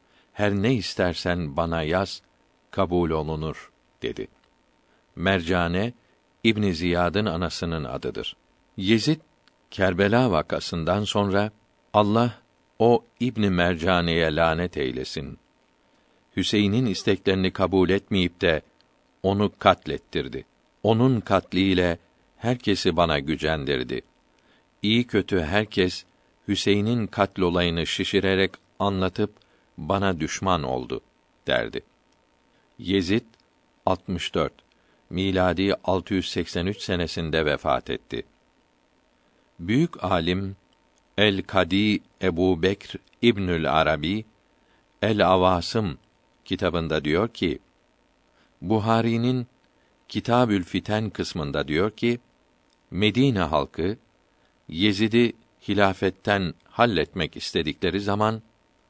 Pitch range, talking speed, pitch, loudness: 90-105 Hz, 80 wpm, 95 Hz, -24 LUFS